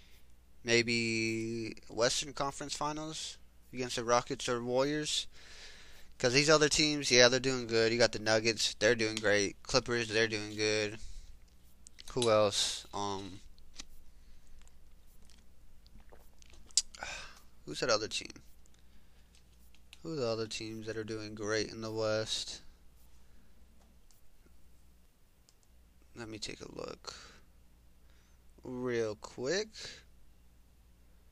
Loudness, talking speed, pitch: -32 LUFS, 100 wpm, 85 Hz